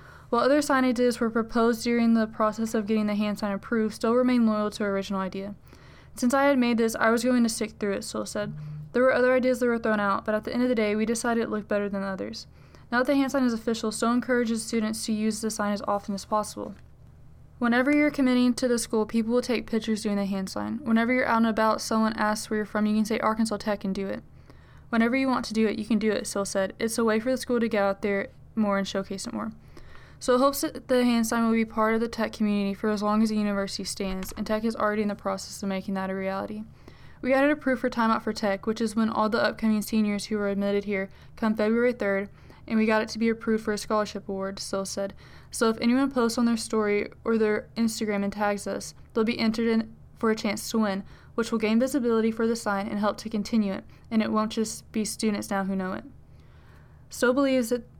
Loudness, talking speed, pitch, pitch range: -26 LUFS, 260 wpm, 220 Hz, 205-235 Hz